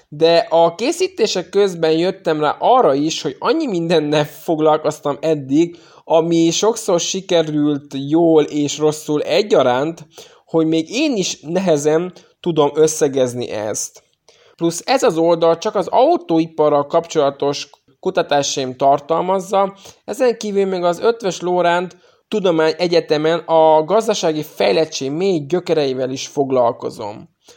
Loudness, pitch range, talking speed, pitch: -17 LUFS, 150-180 Hz, 115 wpm, 165 Hz